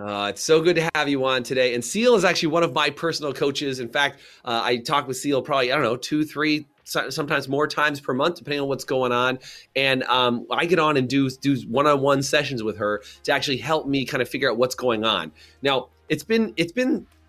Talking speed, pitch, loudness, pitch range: 240 wpm, 140 Hz, -22 LUFS, 125-150 Hz